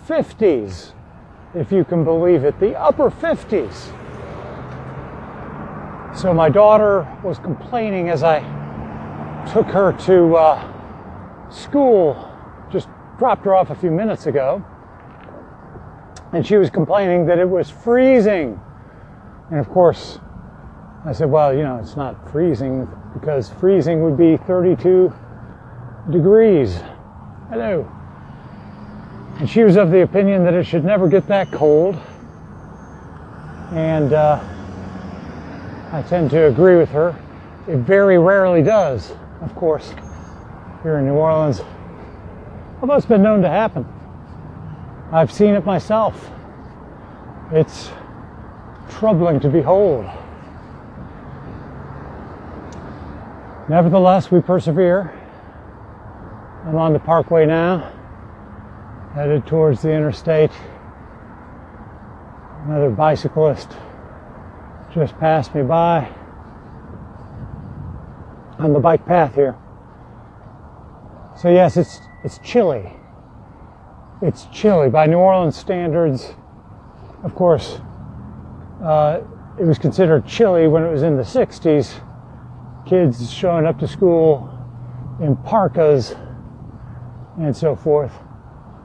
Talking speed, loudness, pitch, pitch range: 105 wpm, -16 LUFS, 155 Hz, 110-175 Hz